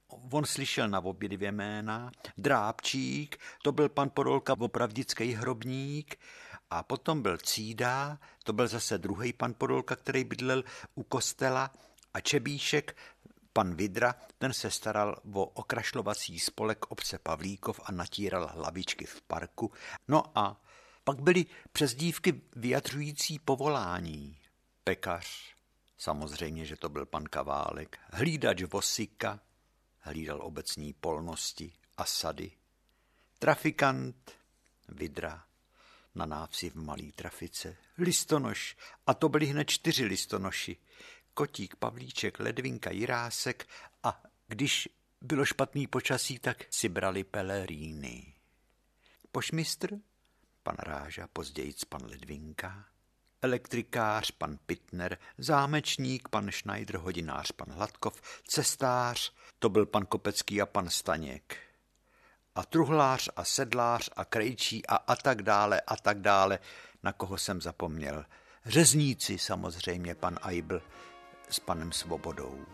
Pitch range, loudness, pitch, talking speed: 90-135 Hz, -32 LUFS, 110 Hz, 115 wpm